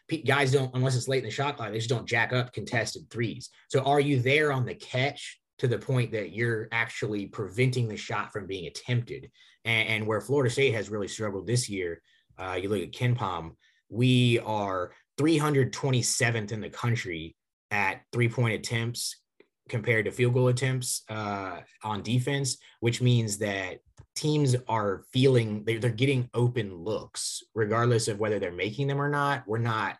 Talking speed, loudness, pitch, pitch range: 180 wpm, -28 LUFS, 120 Hz, 110-130 Hz